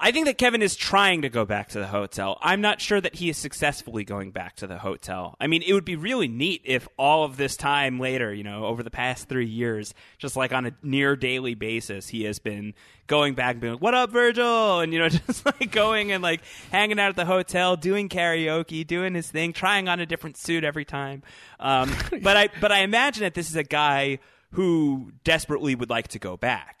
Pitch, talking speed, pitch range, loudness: 150 Hz, 235 wpm, 120-185 Hz, -24 LUFS